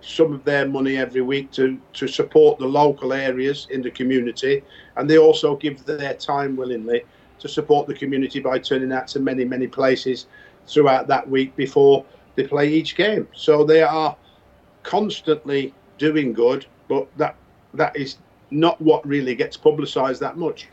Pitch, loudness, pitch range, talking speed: 140 Hz, -20 LUFS, 130-155 Hz, 170 wpm